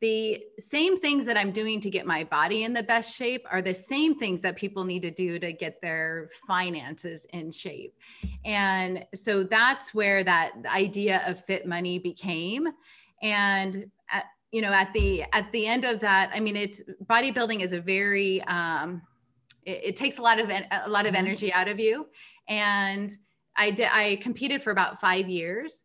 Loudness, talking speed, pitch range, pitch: -26 LUFS, 185 wpm, 180-220 Hz, 200 Hz